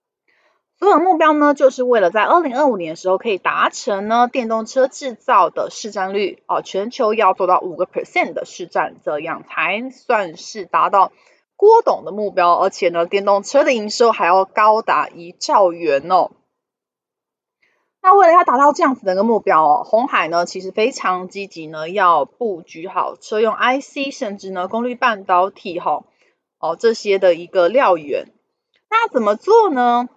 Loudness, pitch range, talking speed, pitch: -16 LUFS, 190-310 Hz, 270 characters per minute, 235 Hz